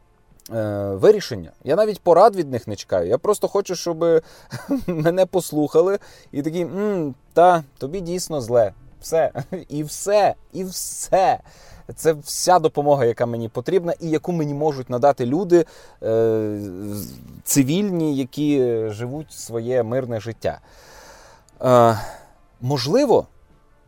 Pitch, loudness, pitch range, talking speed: 145 Hz, -20 LUFS, 120-175 Hz, 110 wpm